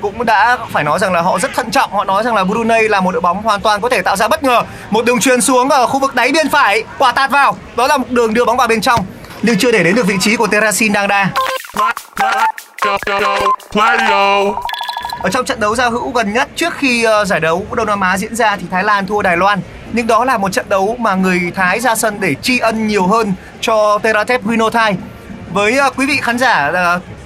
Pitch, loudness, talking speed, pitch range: 225 Hz, -13 LUFS, 240 wpm, 200-260 Hz